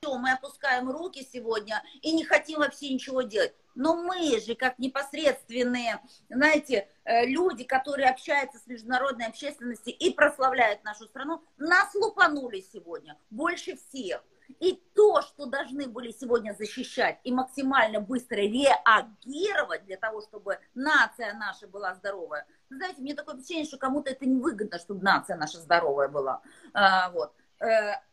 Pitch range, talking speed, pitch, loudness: 225-295 Hz, 135 wpm, 260 Hz, -27 LUFS